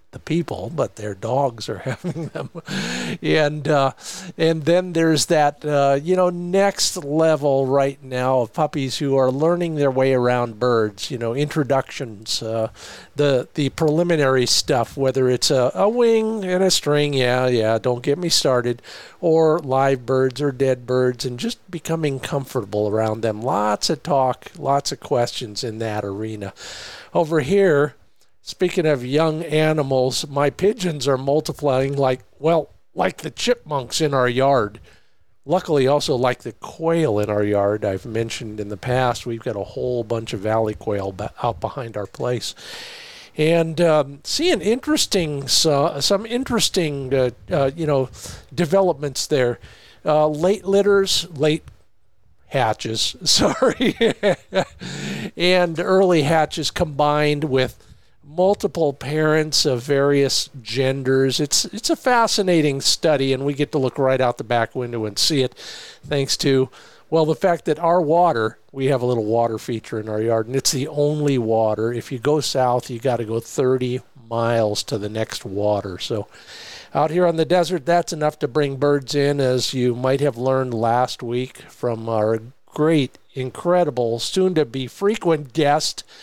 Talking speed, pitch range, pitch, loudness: 160 wpm, 120-160 Hz, 140 Hz, -20 LUFS